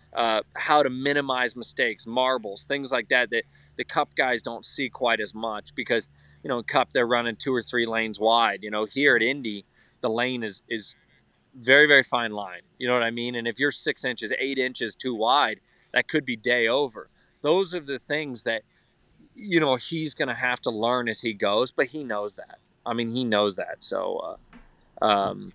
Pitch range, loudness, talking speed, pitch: 115-135 Hz, -25 LUFS, 210 wpm, 120 Hz